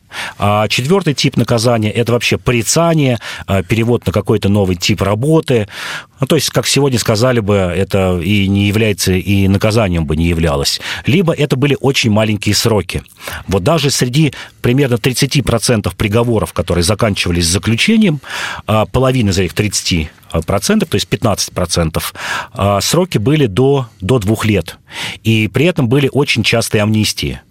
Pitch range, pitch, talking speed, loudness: 100-130 Hz, 110 Hz, 140 wpm, -13 LUFS